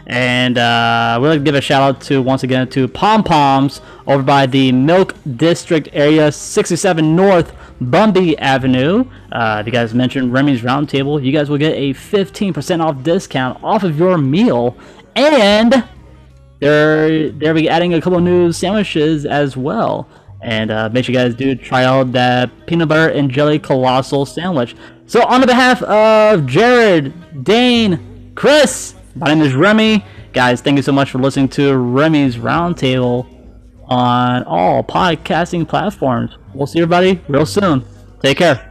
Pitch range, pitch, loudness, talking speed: 125-170 Hz, 145 Hz, -13 LUFS, 160 wpm